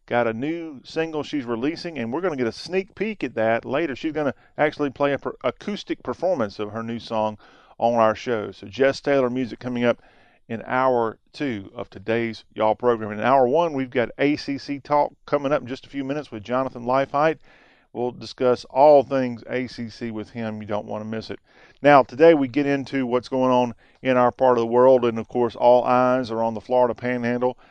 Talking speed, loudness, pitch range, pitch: 215 wpm, -22 LUFS, 115-140 Hz, 125 Hz